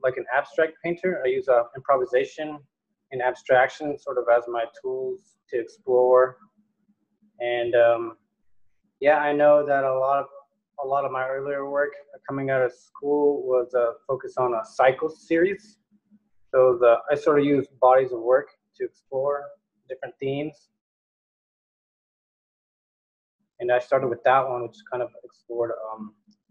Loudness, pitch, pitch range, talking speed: -23 LUFS, 140 Hz, 125-185 Hz, 155 wpm